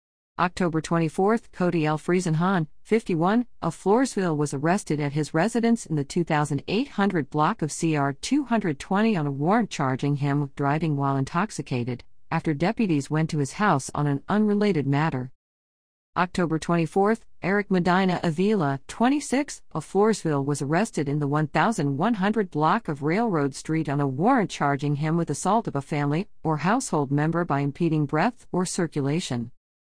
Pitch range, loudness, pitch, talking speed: 145-195 Hz, -25 LUFS, 160 Hz, 150 wpm